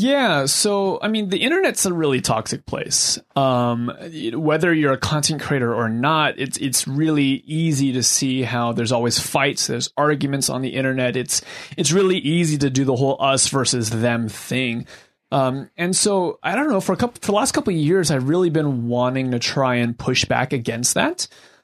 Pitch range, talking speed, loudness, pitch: 125-175 Hz, 195 wpm, -19 LUFS, 140 Hz